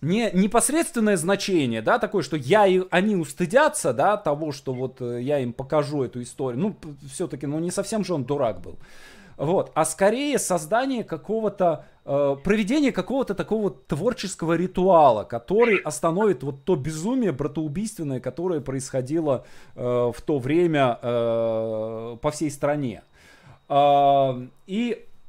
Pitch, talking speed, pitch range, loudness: 165 Hz, 135 wpm, 140-200 Hz, -23 LUFS